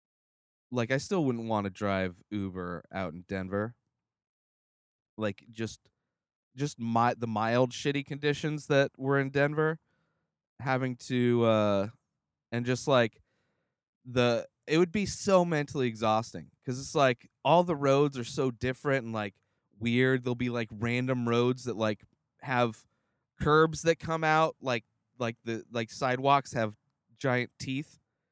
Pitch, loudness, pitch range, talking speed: 125 Hz, -30 LUFS, 110-140 Hz, 145 wpm